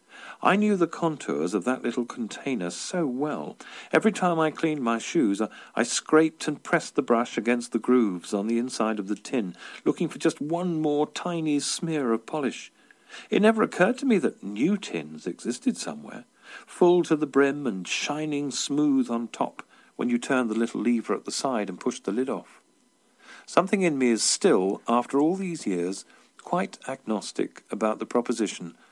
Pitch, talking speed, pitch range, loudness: 130 Hz, 185 wpm, 115-160 Hz, -26 LUFS